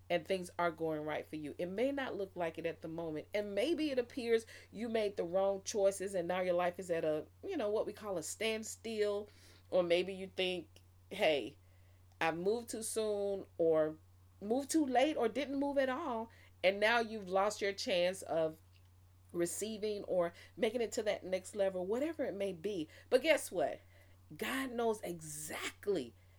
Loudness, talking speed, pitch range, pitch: -37 LUFS, 185 wpm, 165-225 Hz, 195 Hz